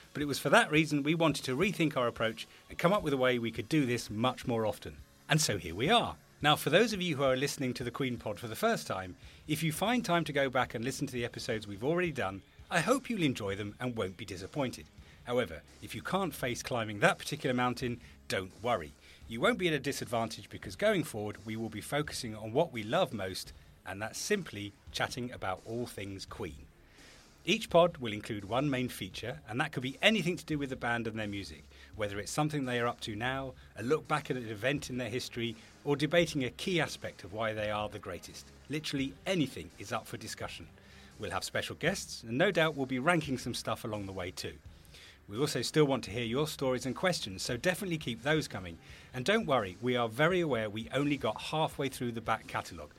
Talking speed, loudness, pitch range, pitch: 235 wpm, -33 LUFS, 105-145 Hz, 125 Hz